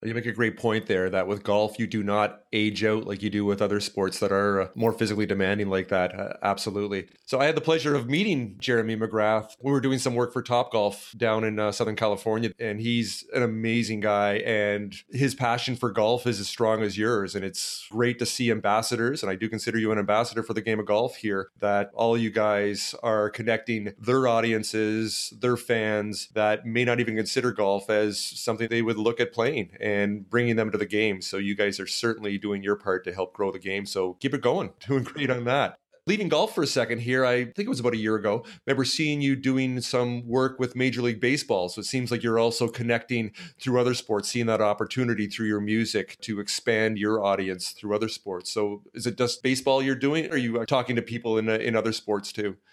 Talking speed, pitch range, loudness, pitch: 230 wpm, 105-120 Hz, -26 LUFS, 110 Hz